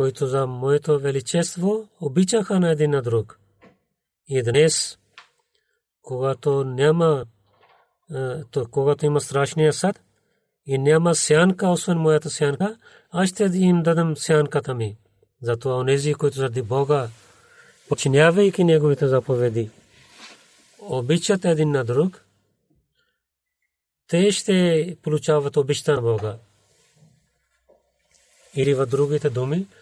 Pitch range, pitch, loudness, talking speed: 135-170 Hz, 150 Hz, -21 LUFS, 105 wpm